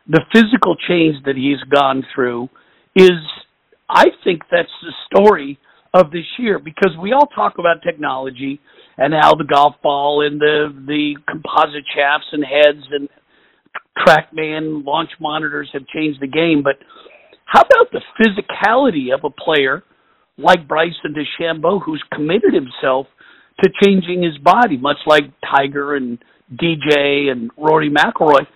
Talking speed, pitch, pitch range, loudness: 145 wpm, 150 Hz, 140-175 Hz, -15 LUFS